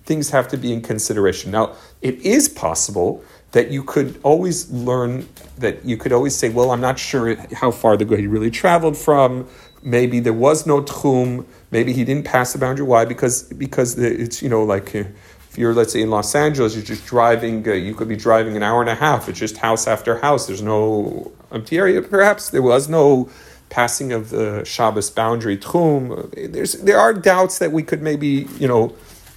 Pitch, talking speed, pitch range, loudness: 125 Hz, 200 wpm, 115-140 Hz, -18 LUFS